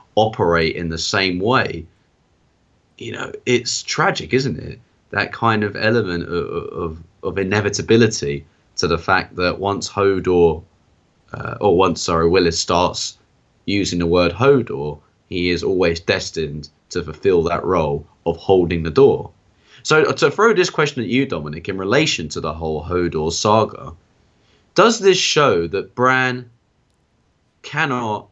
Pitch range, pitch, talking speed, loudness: 85-115 Hz, 95 Hz, 145 wpm, -18 LUFS